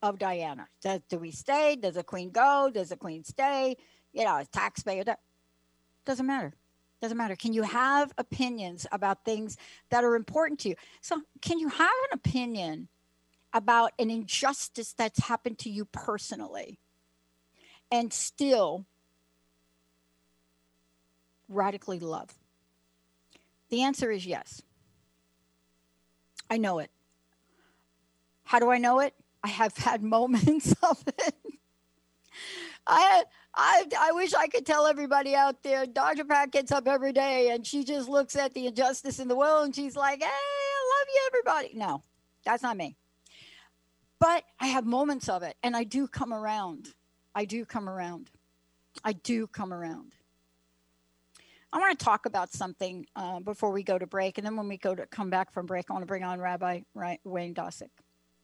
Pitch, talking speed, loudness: 200 Hz, 160 wpm, -29 LUFS